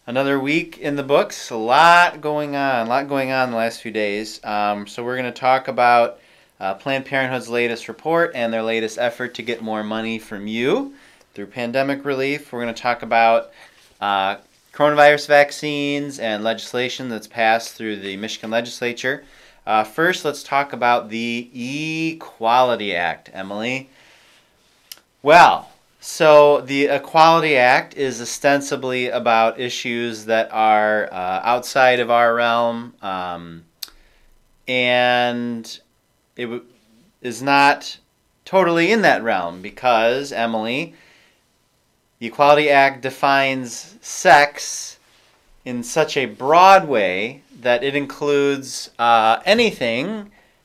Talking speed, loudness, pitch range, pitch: 130 wpm, -18 LUFS, 115-140 Hz, 125 Hz